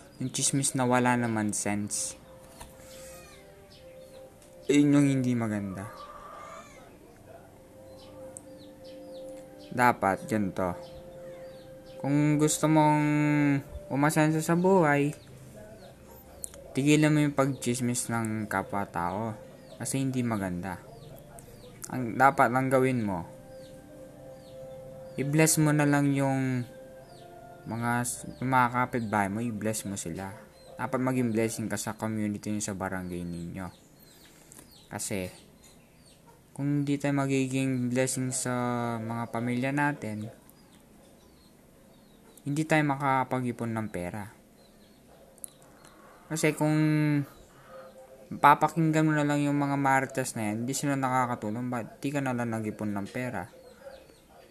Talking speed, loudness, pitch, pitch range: 100 wpm, -28 LUFS, 130 Hz, 115-150 Hz